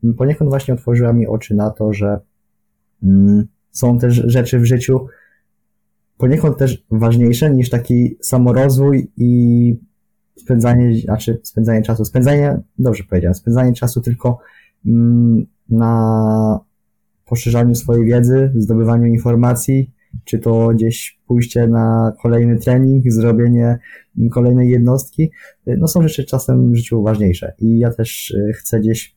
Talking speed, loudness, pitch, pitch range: 120 wpm, -14 LUFS, 120 Hz, 115-125 Hz